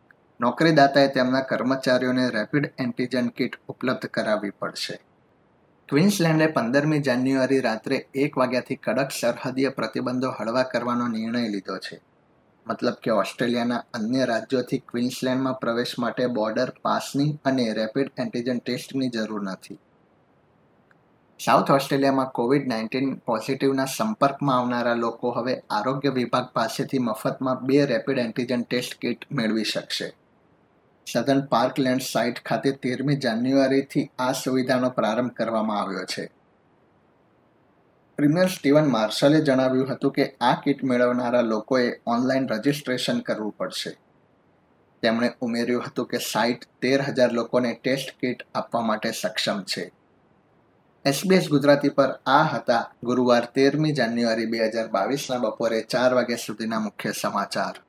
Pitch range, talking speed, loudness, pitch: 120-135 Hz, 120 wpm, -24 LUFS, 130 Hz